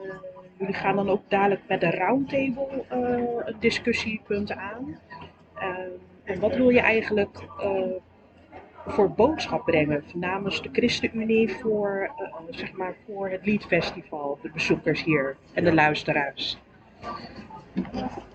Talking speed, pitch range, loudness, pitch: 130 wpm, 175-220 Hz, -26 LUFS, 195 Hz